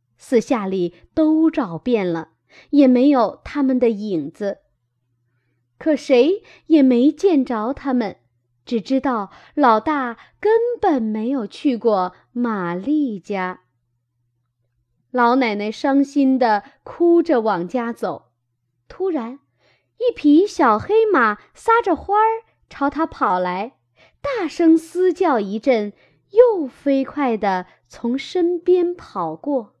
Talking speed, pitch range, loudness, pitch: 155 characters per minute, 190-310 Hz, -19 LUFS, 250 Hz